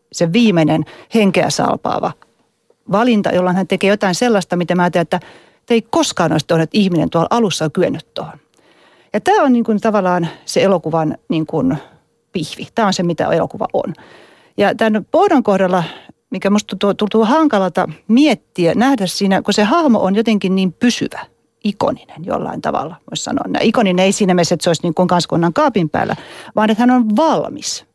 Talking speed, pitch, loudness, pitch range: 175 wpm, 195 Hz, -15 LUFS, 175-225 Hz